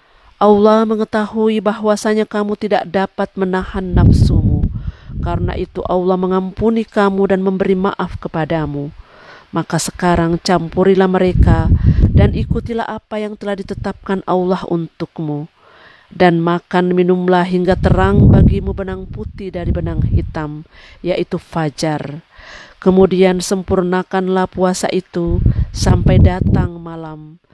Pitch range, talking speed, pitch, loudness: 165-200 Hz, 105 wpm, 185 Hz, -15 LUFS